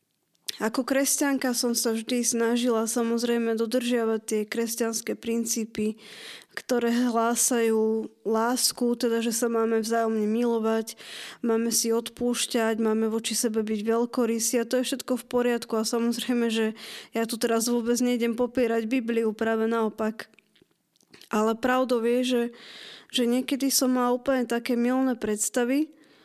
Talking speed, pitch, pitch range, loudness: 135 wpm, 235 Hz, 225-245 Hz, -26 LUFS